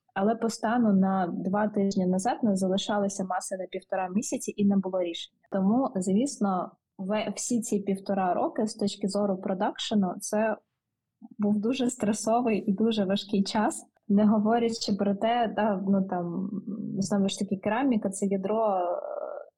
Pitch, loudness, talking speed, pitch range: 205 Hz, -28 LUFS, 145 wpm, 195-220 Hz